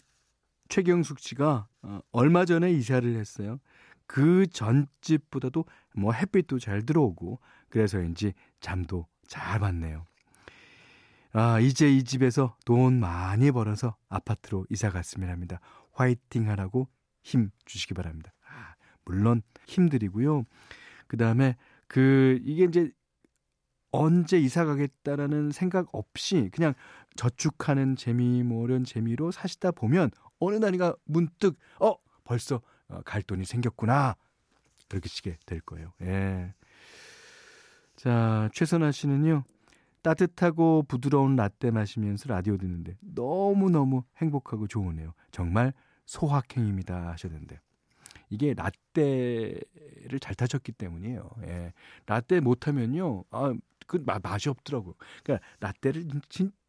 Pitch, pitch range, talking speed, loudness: 125 Hz, 105-150 Hz, 260 characters per minute, -28 LUFS